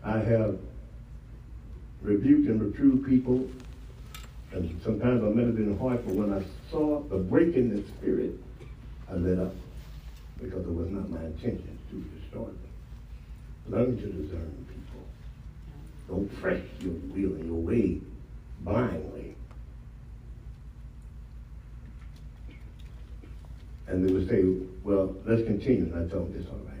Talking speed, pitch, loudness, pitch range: 130 wpm, 95 Hz, -29 LUFS, 80-110 Hz